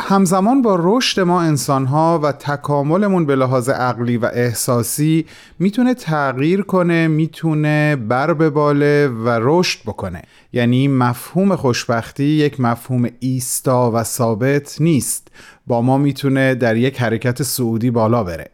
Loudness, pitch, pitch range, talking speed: -16 LUFS, 140 Hz, 120-160 Hz, 135 wpm